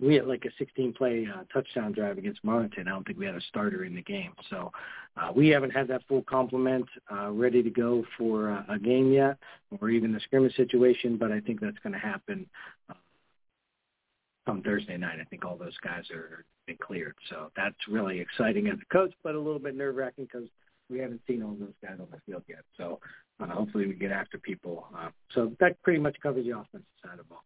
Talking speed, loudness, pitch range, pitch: 225 wpm, -30 LUFS, 120-175 Hz, 130 Hz